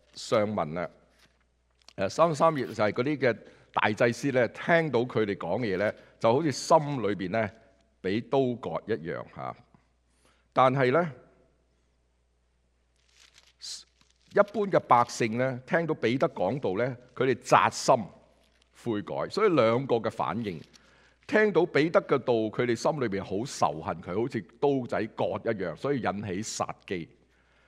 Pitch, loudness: 110 Hz, -28 LUFS